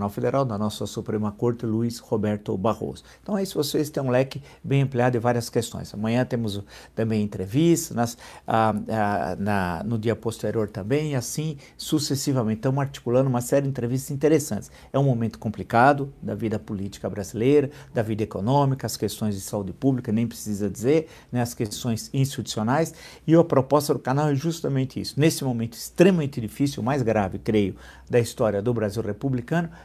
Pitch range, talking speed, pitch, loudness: 110-140 Hz, 170 wpm, 120 Hz, -25 LUFS